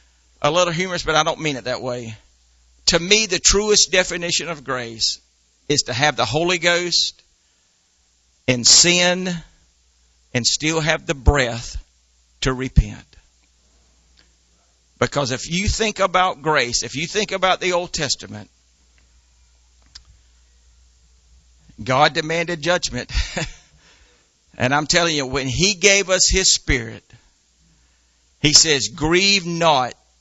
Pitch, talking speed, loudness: 120 Hz, 125 wpm, -17 LUFS